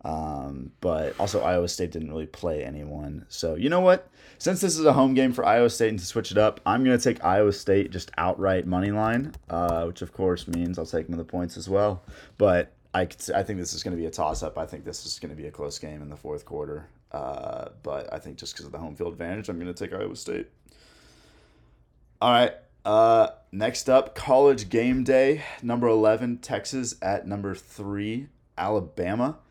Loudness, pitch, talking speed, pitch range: -25 LUFS, 100 Hz, 220 wpm, 85-120 Hz